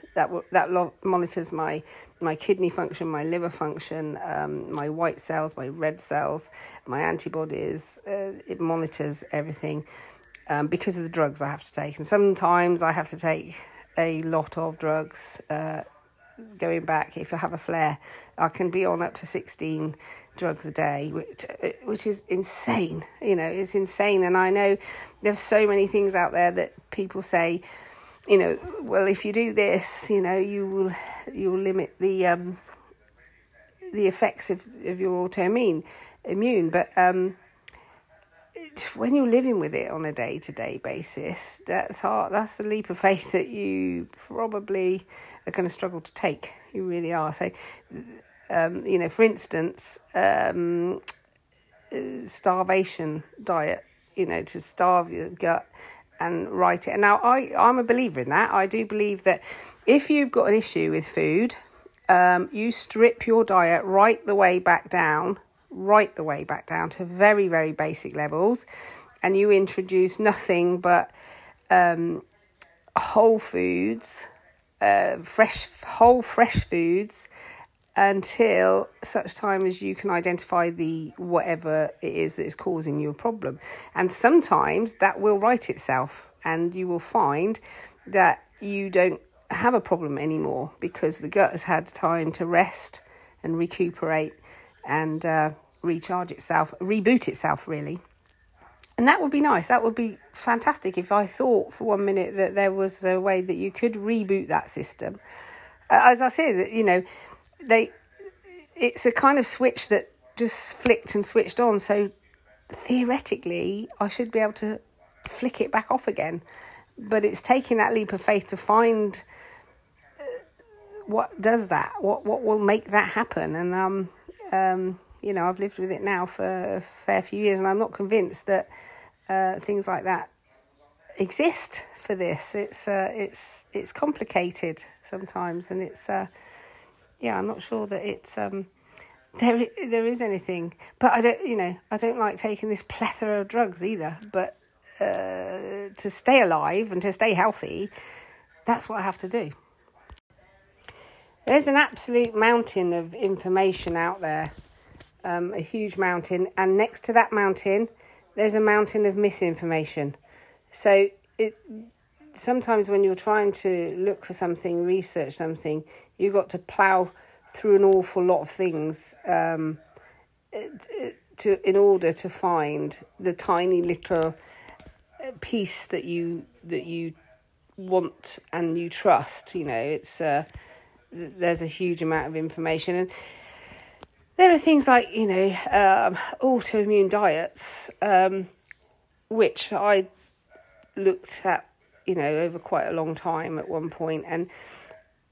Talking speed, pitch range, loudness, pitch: 155 wpm, 170-220 Hz, -24 LUFS, 190 Hz